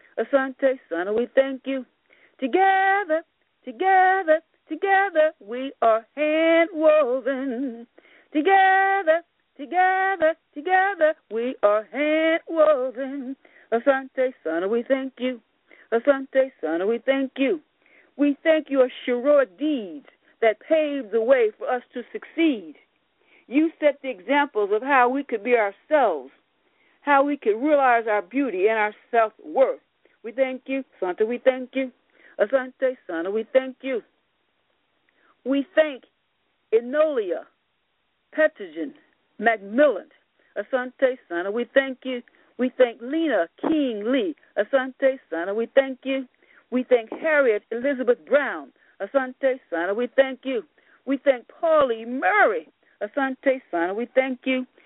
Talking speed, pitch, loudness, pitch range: 125 wpm, 270 Hz, -23 LUFS, 245-310 Hz